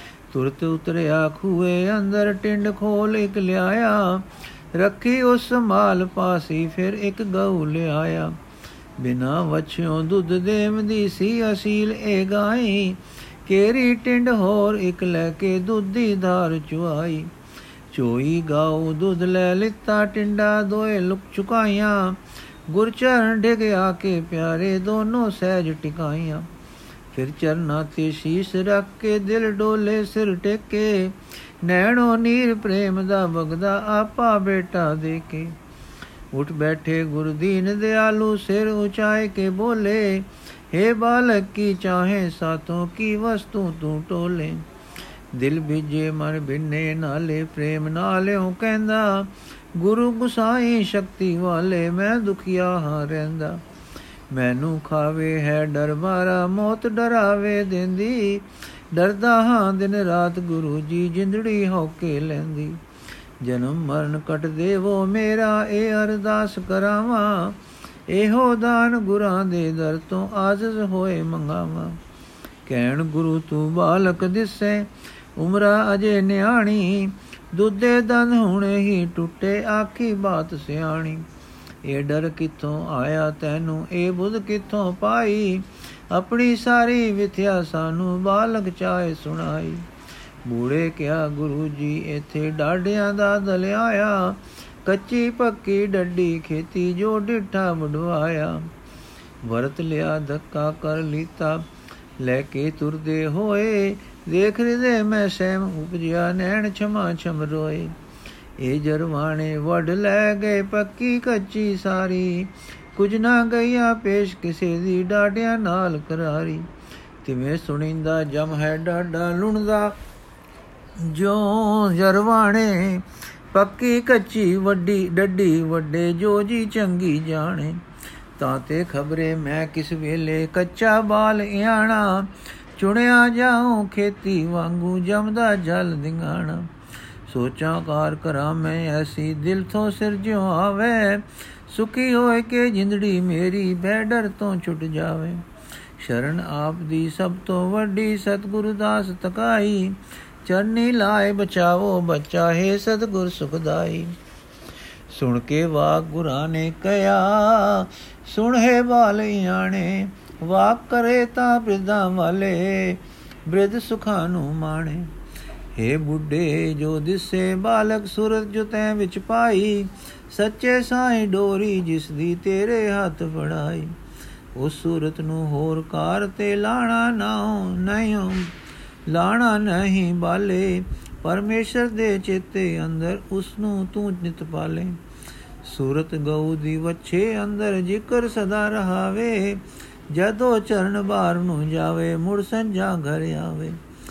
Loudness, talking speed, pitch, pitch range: -21 LUFS, 115 wpm, 185 Hz, 160-210 Hz